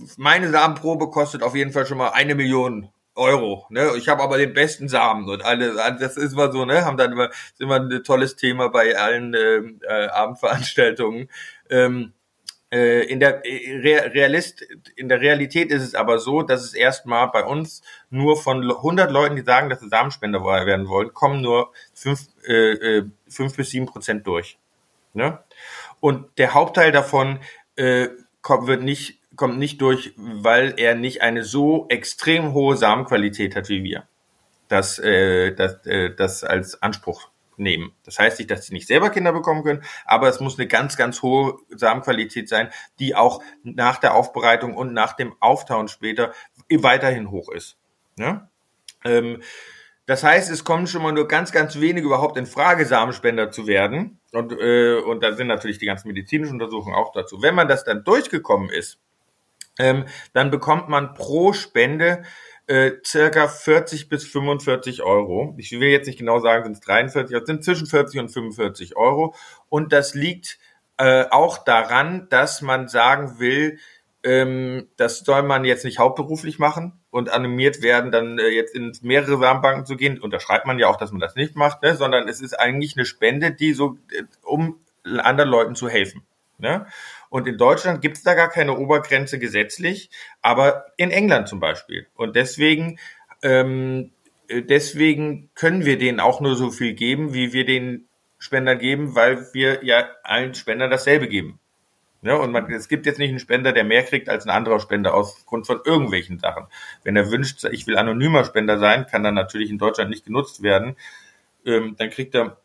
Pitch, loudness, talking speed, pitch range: 130 Hz, -19 LUFS, 180 wpm, 120-145 Hz